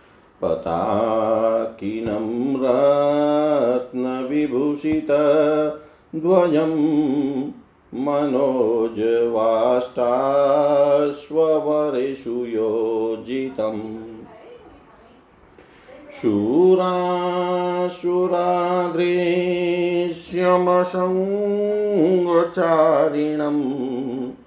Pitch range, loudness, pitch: 125-175 Hz, -20 LUFS, 145 Hz